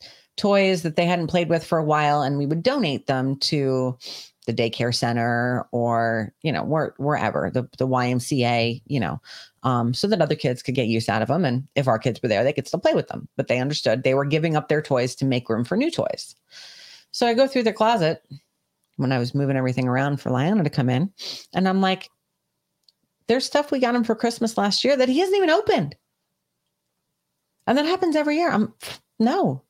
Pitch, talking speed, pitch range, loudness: 145 Hz, 215 wpm, 125-200 Hz, -22 LUFS